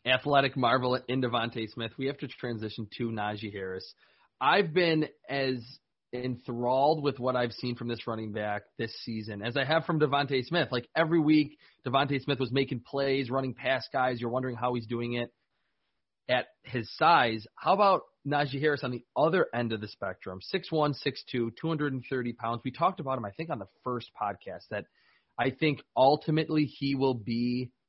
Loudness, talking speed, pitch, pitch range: -30 LUFS, 180 wpm, 130 Hz, 120-140 Hz